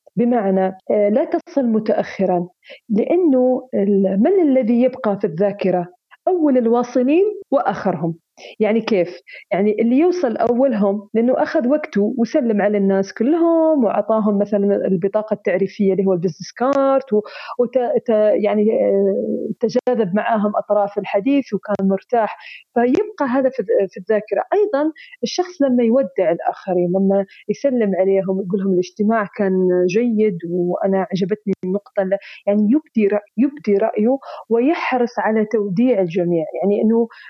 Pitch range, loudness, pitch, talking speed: 195-255 Hz, -18 LUFS, 215 Hz, 120 wpm